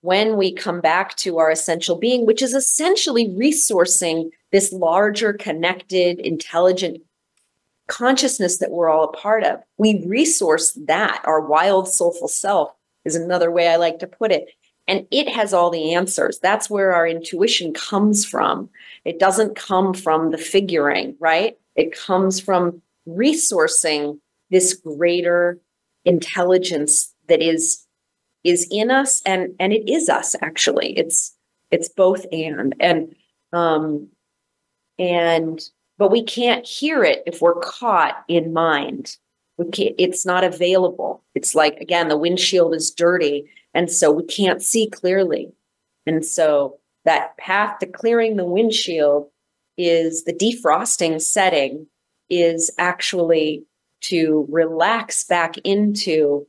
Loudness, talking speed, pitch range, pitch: -18 LUFS, 135 wpm, 165-205 Hz, 180 Hz